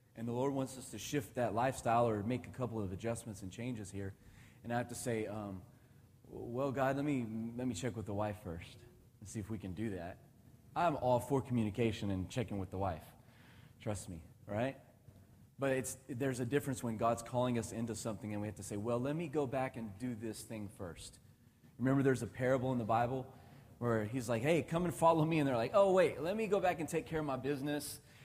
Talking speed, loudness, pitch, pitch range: 235 wpm, -37 LUFS, 120 Hz, 110-130 Hz